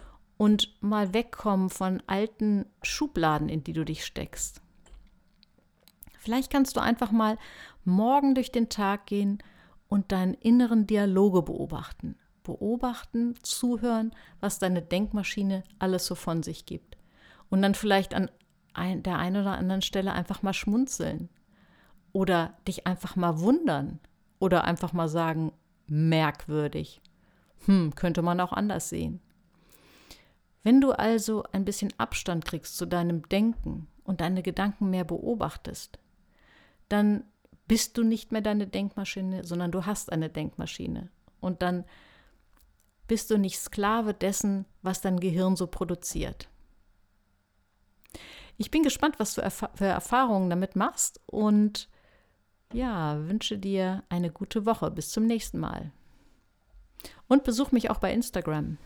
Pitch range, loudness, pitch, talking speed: 175-215 Hz, -28 LUFS, 195 Hz, 135 wpm